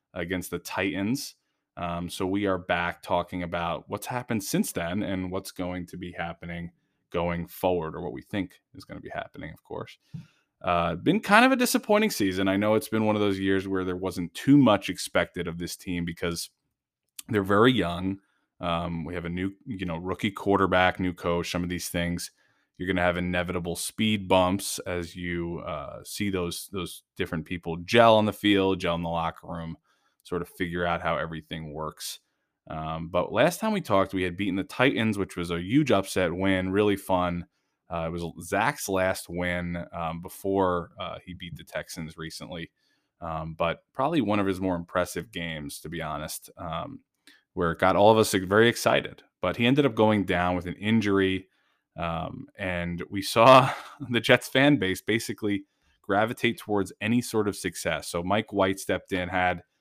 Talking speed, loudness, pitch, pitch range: 190 wpm, -26 LUFS, 90 Hz, 85-100 Hz